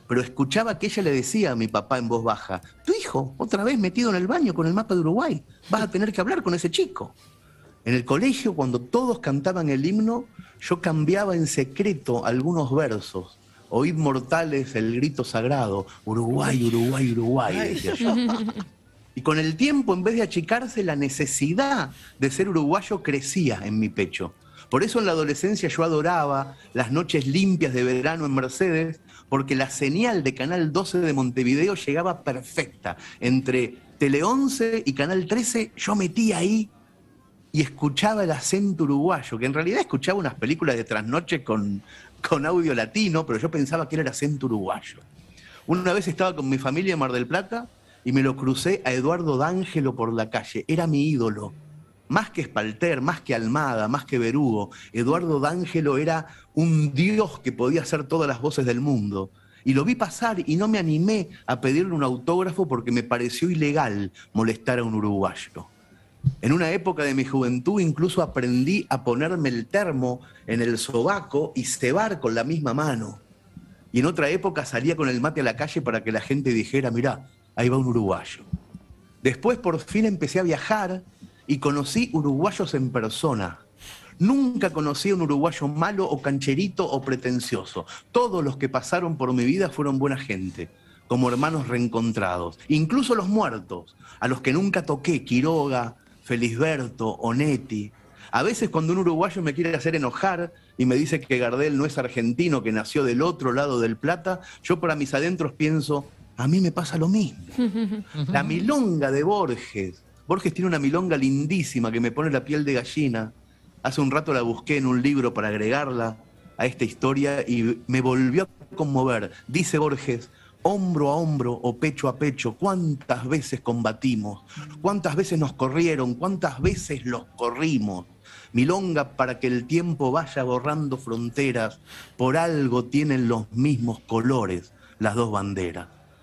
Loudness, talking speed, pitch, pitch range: -24 LUFS, 170 wpm, 140 Hz, 125-170 Hz